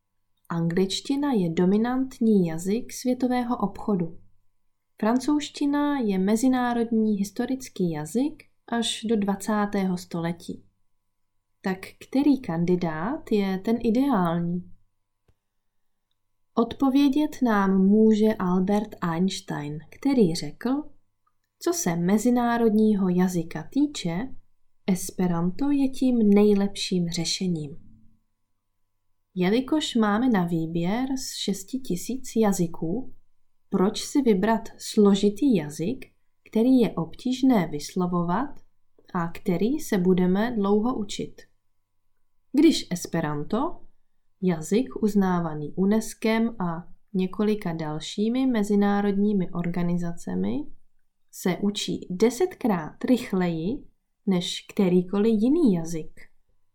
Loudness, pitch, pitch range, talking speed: -25 LUFS, 195 Hz, 165-230 Hz, 85 wpm